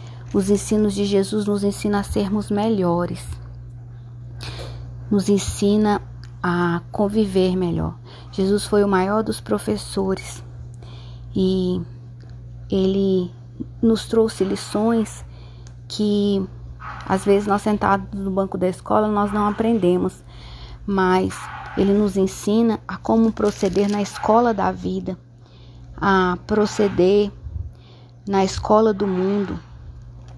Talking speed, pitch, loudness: 105 wpm, 190 Hz, -20 LUFS